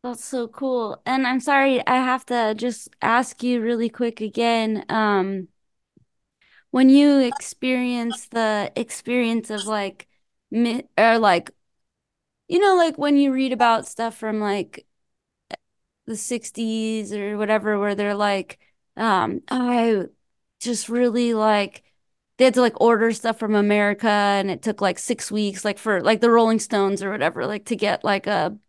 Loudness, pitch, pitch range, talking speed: -21 LUFS, 230 Hz, 210-245 Hz, 155 wpm